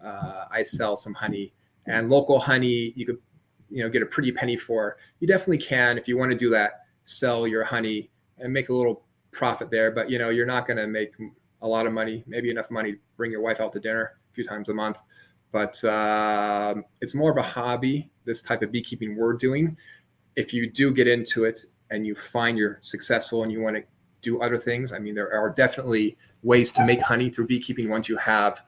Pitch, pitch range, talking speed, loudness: 115 Hz, 110-125 Hz, 225 wpm, -25 LUFS